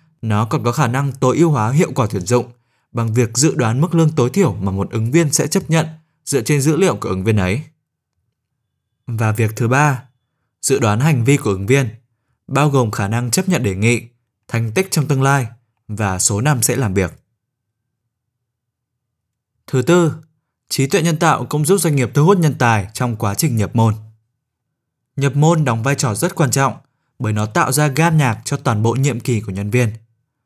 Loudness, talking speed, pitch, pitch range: -16 LUFS, 210 wpm, 125 Hz, 115-150 Hz